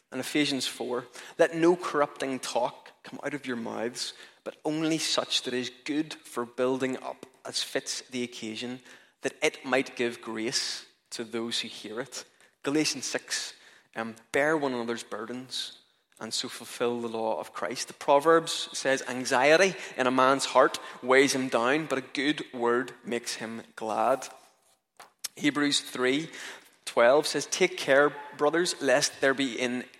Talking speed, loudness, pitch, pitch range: 155 wpm, -28 LUFS, 130 Hz, 120-145 Hz